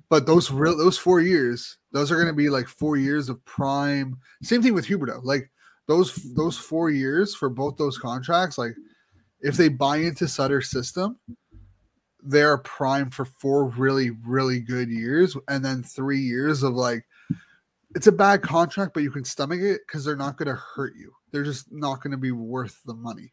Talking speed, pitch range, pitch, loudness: 195 wpm, 130-165 Hz, 140 Hz, -23 LUFS